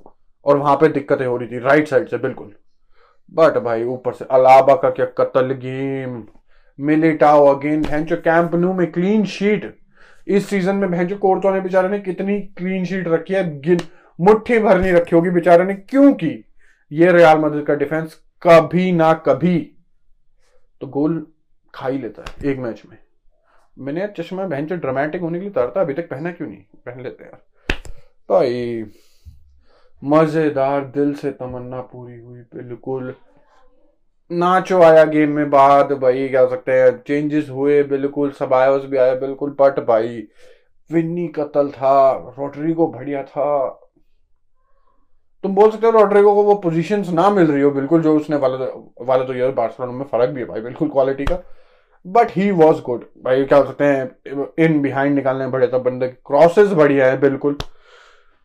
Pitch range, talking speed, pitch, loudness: 135-180 Hz, 140 wpm, 150 Hz, -17 LUFS